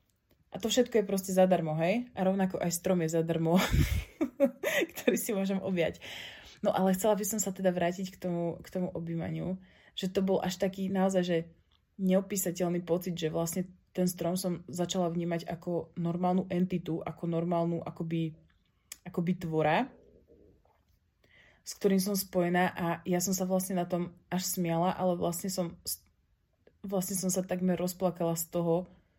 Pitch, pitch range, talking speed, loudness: 180 Hz, 170-190 Hz, 160 wpm, -31 LUFS